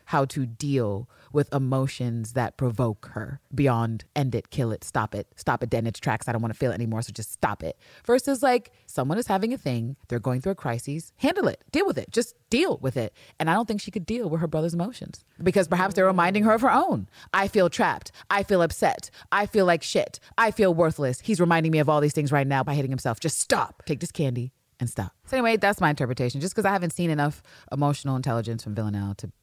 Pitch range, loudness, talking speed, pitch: 120-185 Hz, -25 LUFS, 240 wpm, 145 Hz